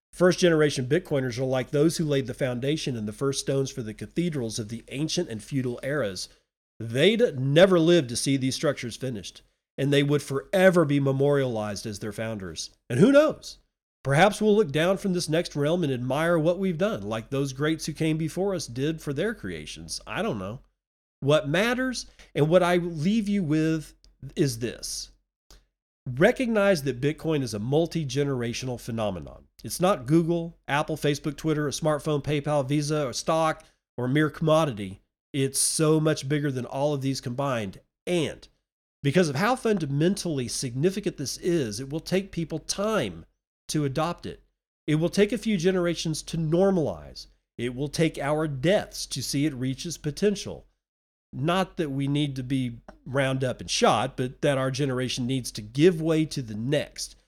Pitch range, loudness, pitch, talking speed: 130-170 Hz, -26 LUFS, 145 Hz, 175 wpm